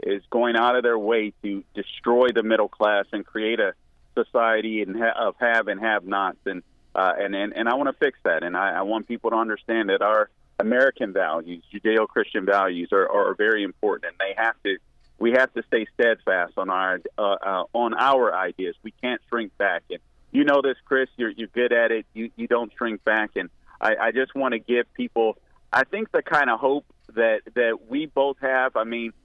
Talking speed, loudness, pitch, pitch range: 215 wpm, -23 LUFS, 115 Hz, 110-130 Hz